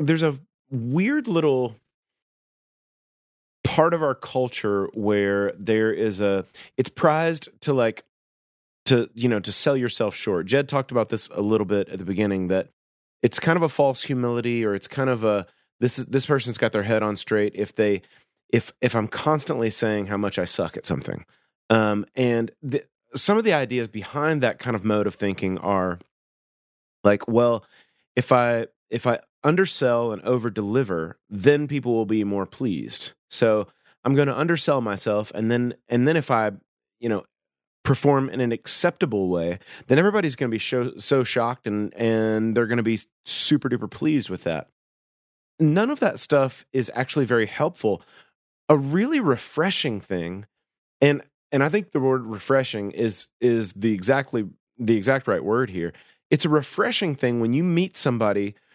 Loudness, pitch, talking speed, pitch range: -23 LUFS, 120 Hz, 175 wpm, 105-140 Hz